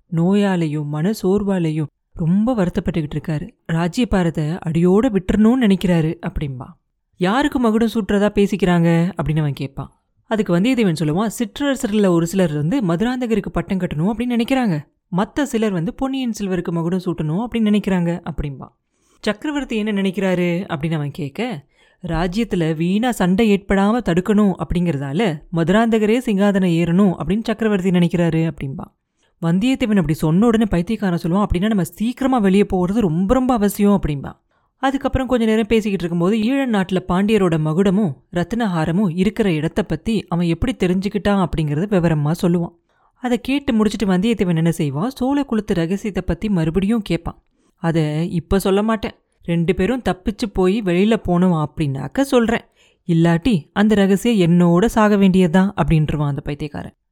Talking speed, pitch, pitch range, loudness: 130 wpm, 190 Hz, 170-220 Hz, -18 LUFS